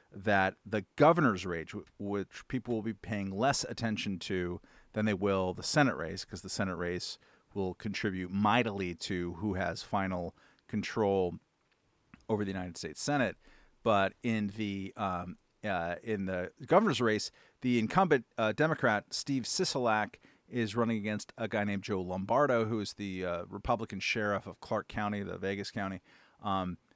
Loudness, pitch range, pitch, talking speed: -33 LUFS, 95-110 Hz, 100 Hz, 160 wpm